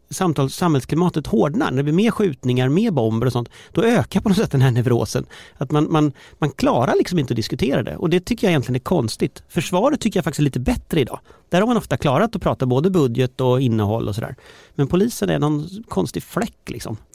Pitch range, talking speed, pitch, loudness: 130-185 Hz, 225 wpm, 150 Hz, -20 LUFS